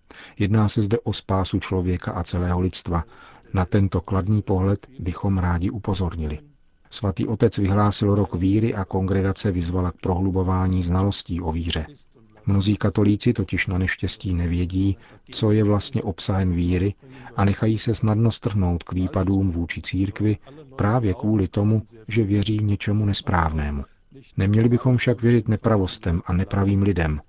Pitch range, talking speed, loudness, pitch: 90-110 Hz, 140 wpm, -22 LUFS, 100 Hz